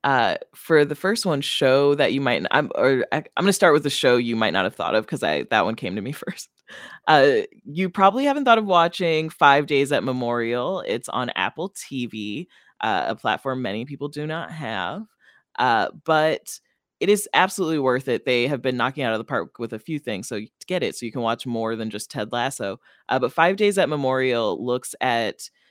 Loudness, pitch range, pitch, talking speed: -22 LUFS, 120-170 Hz, 140 Hz, 225 wpm